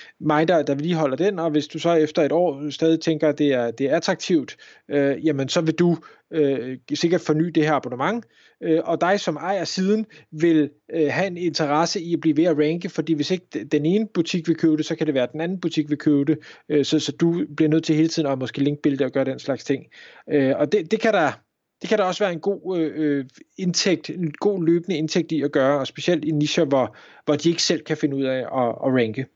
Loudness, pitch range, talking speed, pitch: -22 LUFS, 145-170 Hz, 245 wpm, 155 Hz